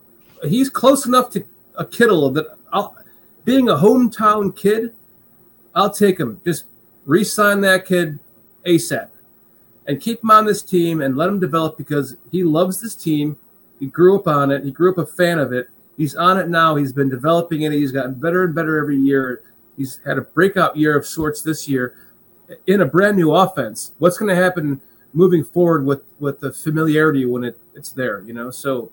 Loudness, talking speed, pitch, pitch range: -17 LUFS, 195 wpm, 160 Hz, 140-185 Hz